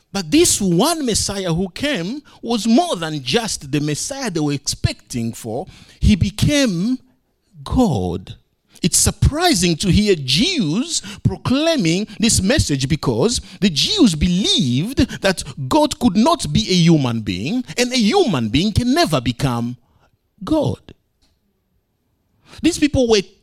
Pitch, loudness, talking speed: 195 Hz, -17 LUFS, 130 wpm